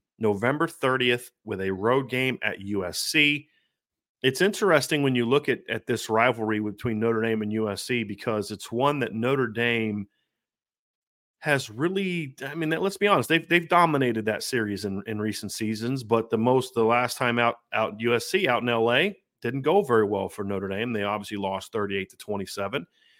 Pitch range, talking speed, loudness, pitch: 105-135 Hz, 180 wpm, -25 LUFS, 120 Hz